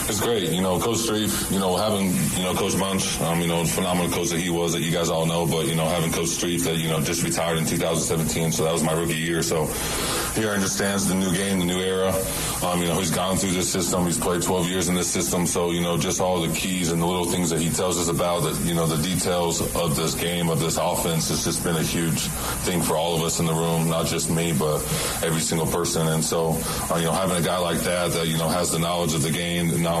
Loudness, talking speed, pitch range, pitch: -23 LUFS, 265 wpm, 80-90 Hz, 85 Hz